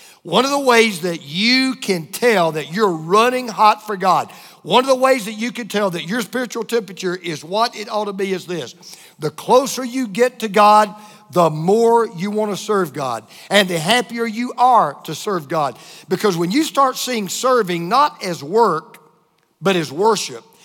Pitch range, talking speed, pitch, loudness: 175-240 Hz, 195 wpm, 210 Hz, -17 LUFS